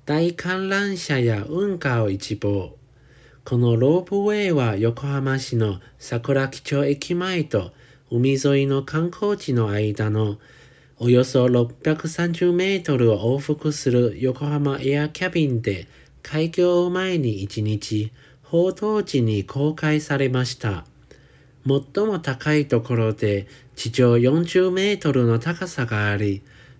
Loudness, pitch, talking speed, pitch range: -22 LUFS, 135 Hz, 200 characters per minute, 115-160 Hz